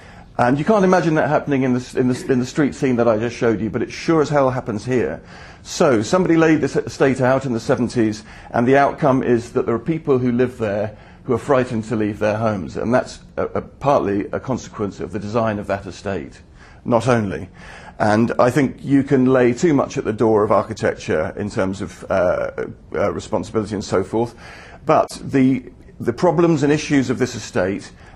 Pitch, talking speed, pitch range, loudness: 125 Hz, 210 wpm, 110-140 Hz, -19 LUFS